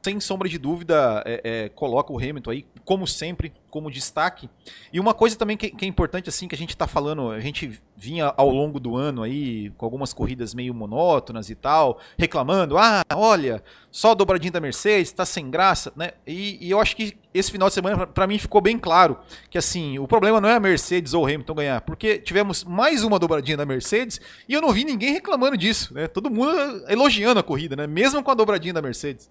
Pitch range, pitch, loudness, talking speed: 145-210 Hz, 175 Hz, -21 LUFS, 220 wpm